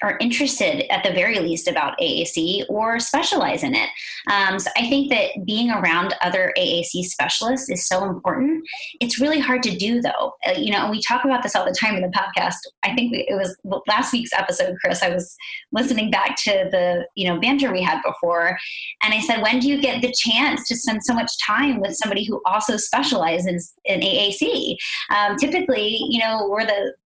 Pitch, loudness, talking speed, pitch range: 225 Hz, -20 LUFS, 205 wpm, 195-265 Hz